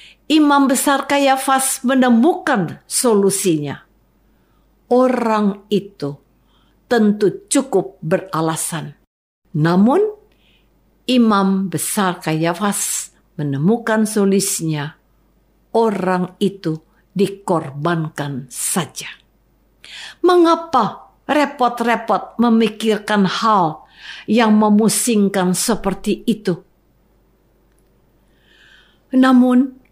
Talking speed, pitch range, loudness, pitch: 60 wpm, 180-250 Hz, -17 LUFS, 205 Hz